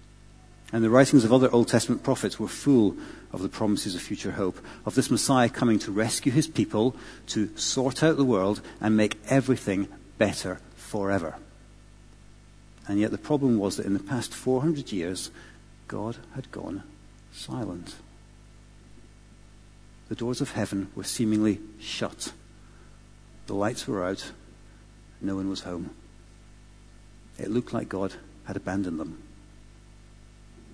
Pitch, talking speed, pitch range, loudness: 110 Hz, 140 wpm, 105-120 Hz, -27 LUFS